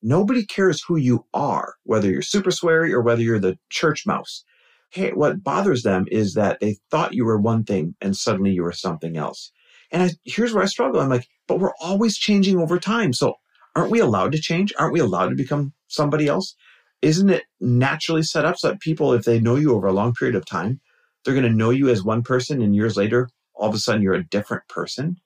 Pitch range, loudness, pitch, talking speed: 110-170 Hz, -21 LUFS, 125 Hz, 230 wpm